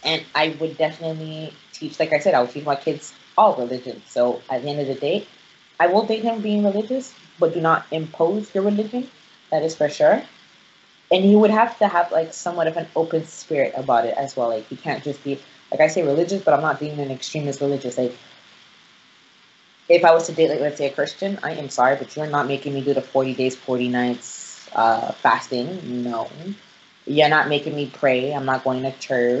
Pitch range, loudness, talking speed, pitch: 135-165 Hz, -21 LUFS, 220 wpm, 150 Hz